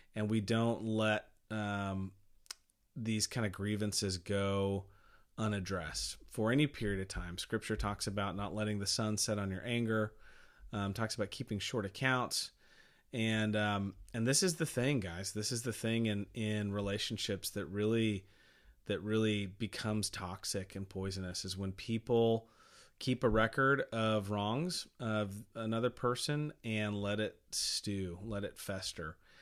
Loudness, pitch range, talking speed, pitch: -36 LUFS, 100-115 Hz, 150 wpm, 105 Hz